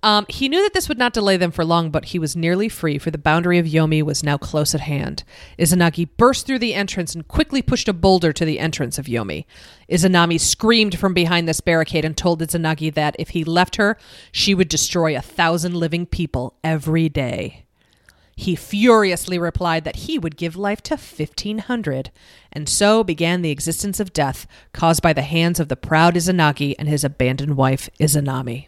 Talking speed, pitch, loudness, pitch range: 195 wpm, 165 Hz, -19 LUFS, 155-190 Hz